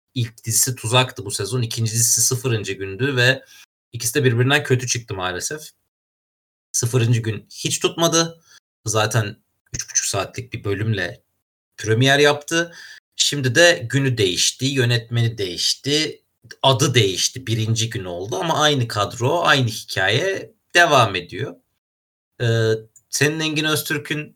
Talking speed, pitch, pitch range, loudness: 125 wpm, 125 Hz, 110-145 Hz, -19 LUFS